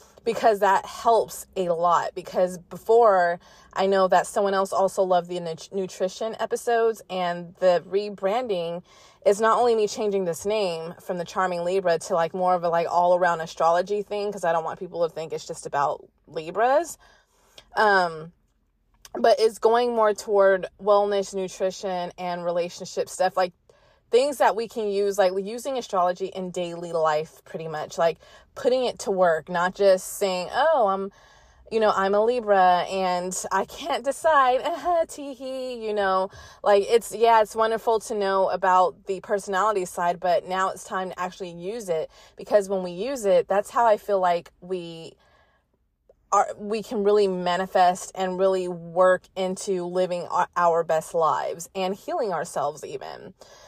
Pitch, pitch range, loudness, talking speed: 190 Hz, 180-215 Hz, -24 LUFS, 165 wpm